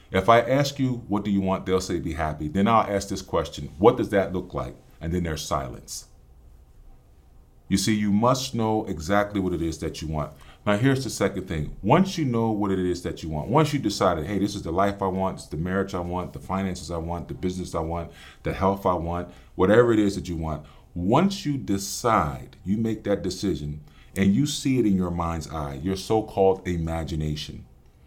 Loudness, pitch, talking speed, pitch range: -25 LUFS, 95 Hz, 220 wpm, 80-105 Hz